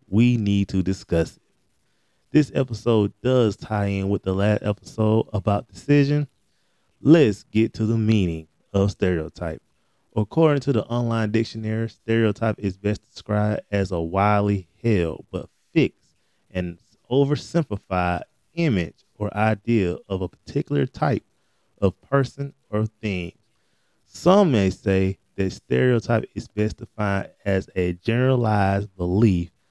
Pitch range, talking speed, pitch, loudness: 95-115 Hz, 125 wpm, 105 Hz, -23 LUFS